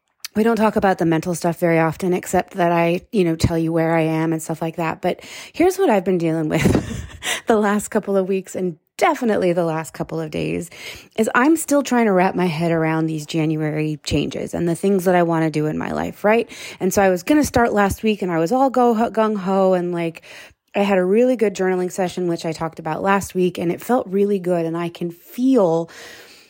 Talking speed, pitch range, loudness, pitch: 240 wpm, 165-210 Hz, -19 LUFS, 180 Hz